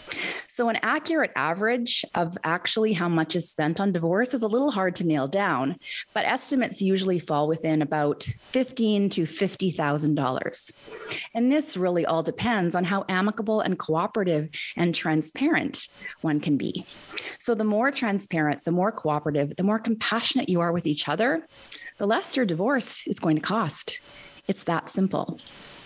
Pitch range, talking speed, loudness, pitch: 160-230 Hz, 160 wpm, -25 LUFS, 190 Hz